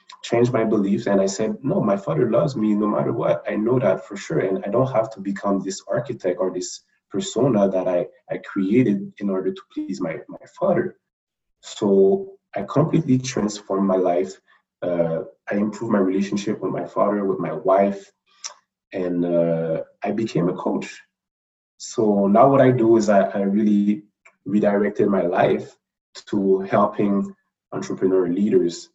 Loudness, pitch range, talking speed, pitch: -21 LUFS, 95-110 Hz, 165 wpm, 100 Hz